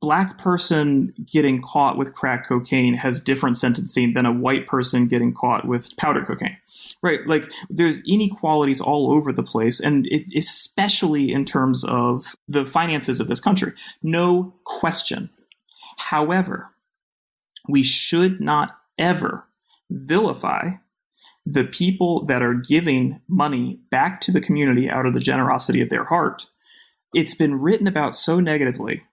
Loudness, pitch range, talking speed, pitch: -20 LUFS, 130-180 Hz, 140 wpm, 150 Hz